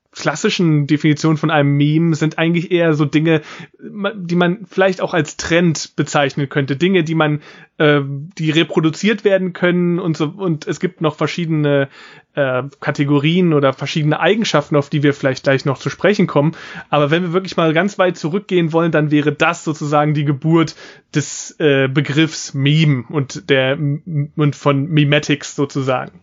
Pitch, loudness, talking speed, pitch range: 155 Hz, -16 LUFS, 165 wpm, 145-170 Hz